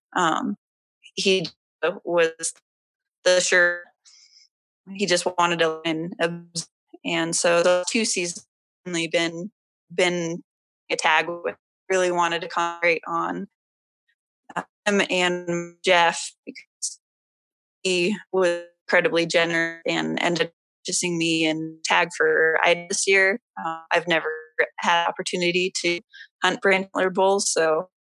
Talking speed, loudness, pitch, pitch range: 120 wpm, -22 LUFS, 175 Hz, 165-185 Hz